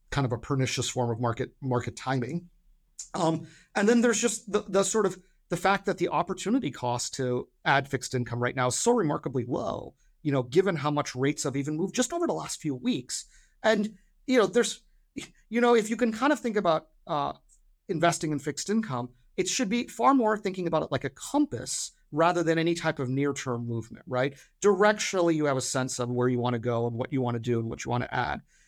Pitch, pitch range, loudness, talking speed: 160 Hz, 130-205 Hz, -28 LUFS, 230 wpm